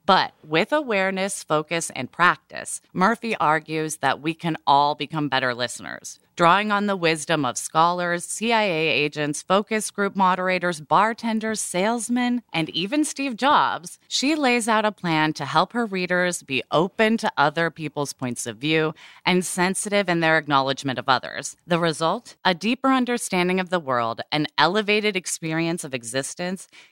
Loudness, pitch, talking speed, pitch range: -22 LUFS, 175 Hz, 155 wpm, 150-210 Hz